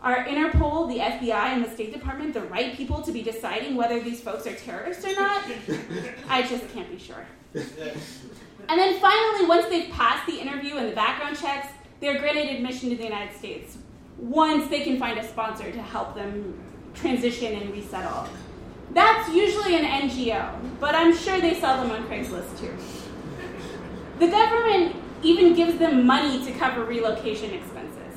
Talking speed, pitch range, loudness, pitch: 170 wpm, 235-335 Hz, -24 LUFS, 275 Hz